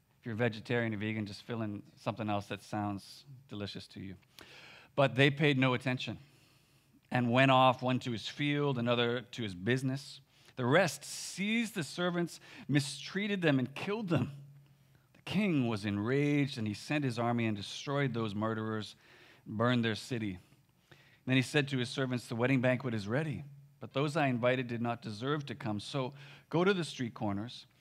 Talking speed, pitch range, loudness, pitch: 180 wpm, 115-140 Hz, -33 LUFS, 130 Hz